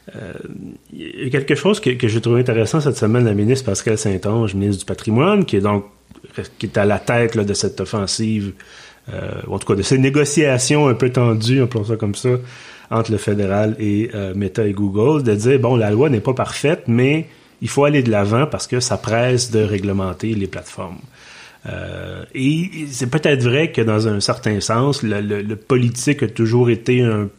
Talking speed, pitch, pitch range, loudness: 210 wpm, 115 Hz, 105-130 Hz, -17 LUFS